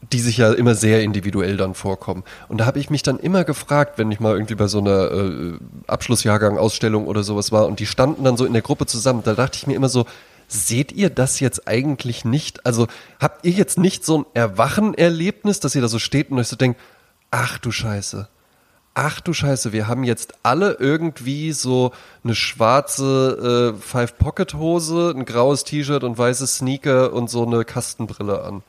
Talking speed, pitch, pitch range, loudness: 195 wpm, 120 Hz, 110-140 Hz, -19 LUFS